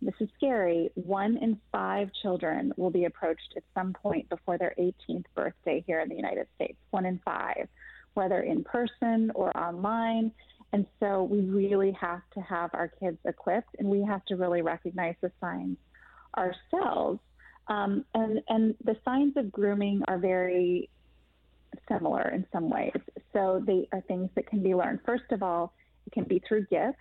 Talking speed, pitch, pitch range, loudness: 175 wpm, 195 Hz, 180-220 Hz, -30 LUFS